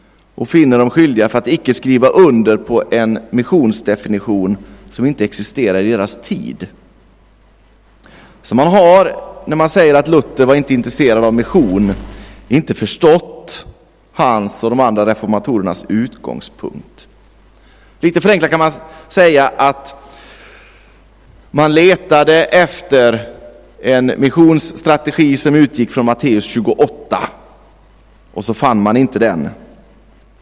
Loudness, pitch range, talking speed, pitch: -12 LUFS, 110-150 Hz, 120 wpm, 125 Hz